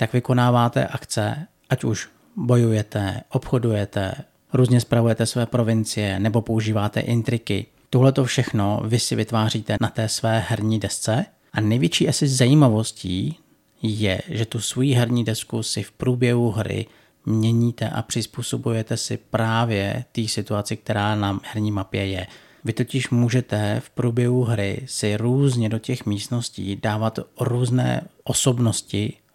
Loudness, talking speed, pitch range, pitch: -22 LUFS, 135 wpm, 110-125 Hz, 115 Hz